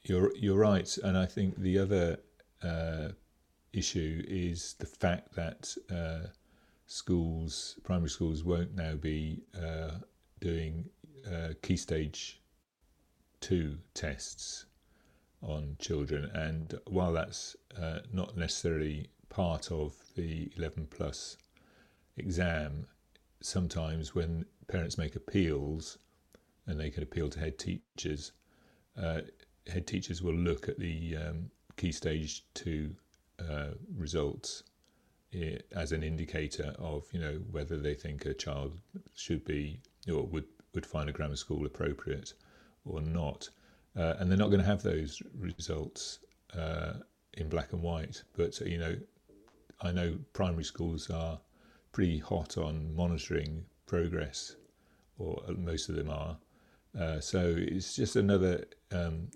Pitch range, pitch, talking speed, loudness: 75-90 Hz, 80 Hz, 130 wpm, -36 LUFS